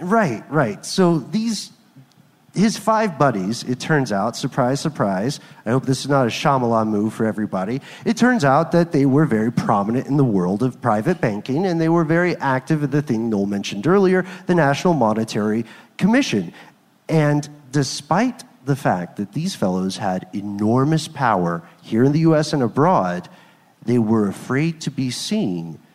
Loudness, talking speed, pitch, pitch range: -20 LUFS, 170 wpm, 140 Hz, 110-165 Hz